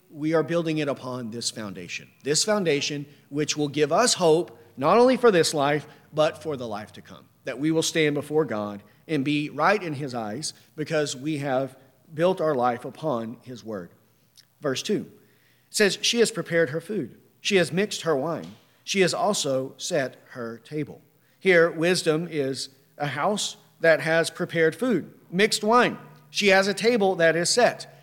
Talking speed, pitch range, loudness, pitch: 180 wpm, 135-175 Hz, -24 LUFS, 155 Hz